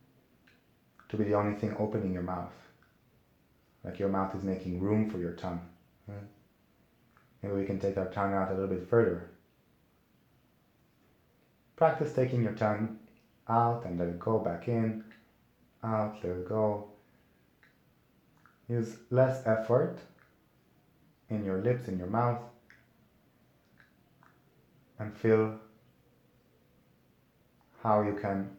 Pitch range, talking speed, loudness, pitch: 95-110 Hz, 120 wpm, -32 LUFS, 105 Hz